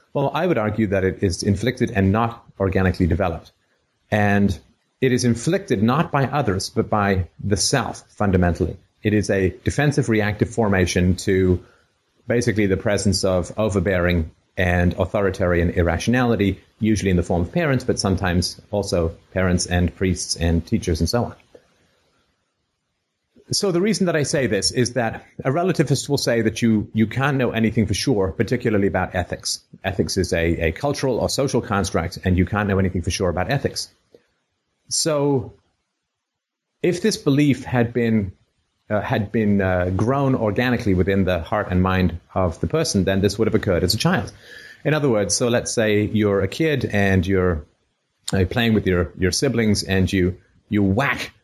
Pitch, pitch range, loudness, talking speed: 100 Hz, 95-120 Hz, -21 LUFS, 170 wpm